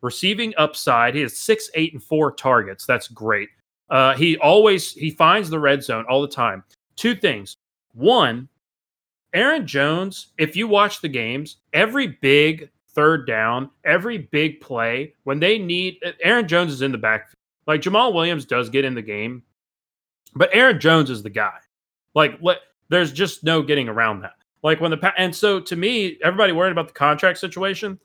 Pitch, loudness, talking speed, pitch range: 155 Hz, -19 LUFS, 180 wpm, 120-180 Hz